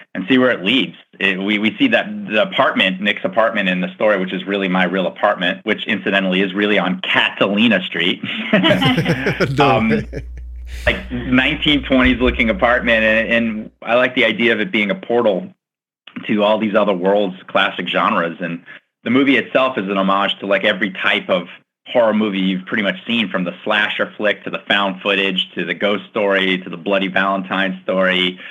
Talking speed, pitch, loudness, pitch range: 185 wpm, 100 Hz, -16 LUFS, 95-120 Hz